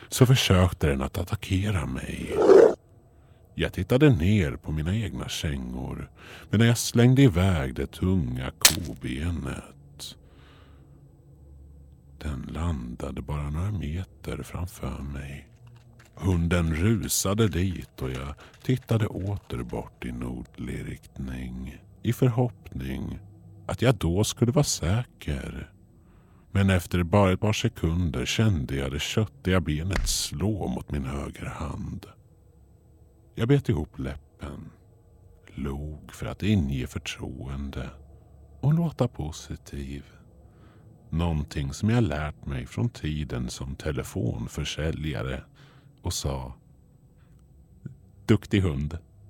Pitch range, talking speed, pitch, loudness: 70-105 Hz, 105 wpm, 85 Hz, -26 LUFS